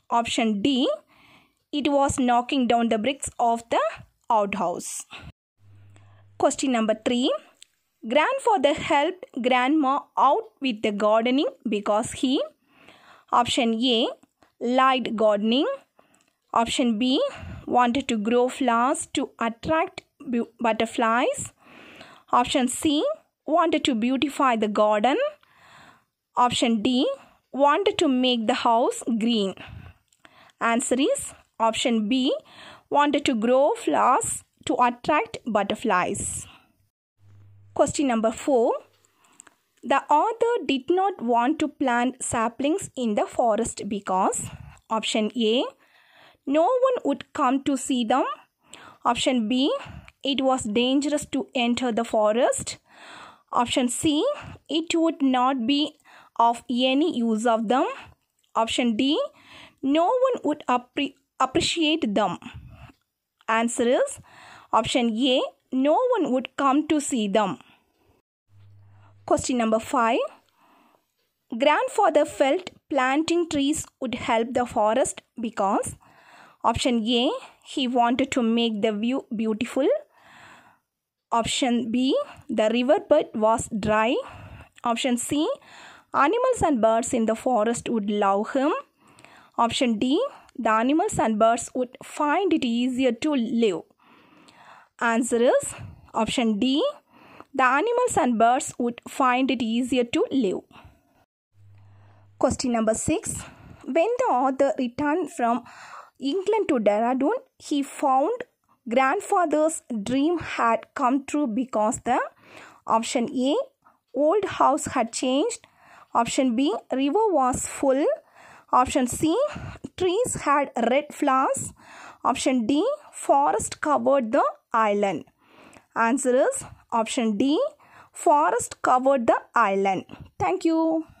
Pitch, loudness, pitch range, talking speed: 260 Hz, -23 LUFS, 230-295 Hz, 110 wpm